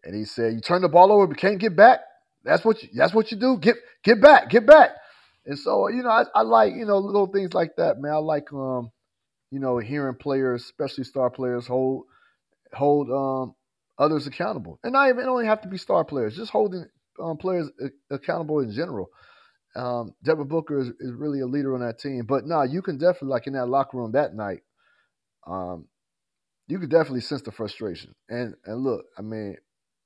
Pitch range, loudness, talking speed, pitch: 125-190 Hz, -22 LUFS, 215 wpm, 145 Hz